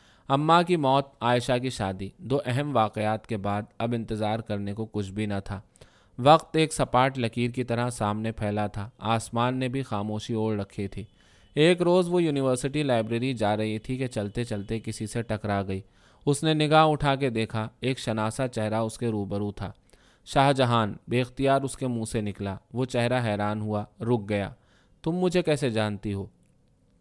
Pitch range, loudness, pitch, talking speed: 105-130 Hz, -27 LUFS, 115 Hz, 185 wpm